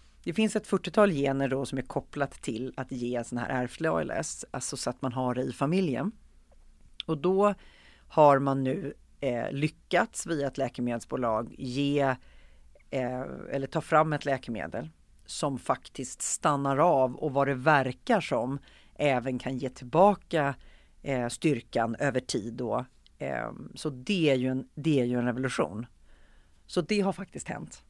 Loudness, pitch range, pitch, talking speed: -29 LUFS, 125-150 Hz, 130 Hz, 160 wpm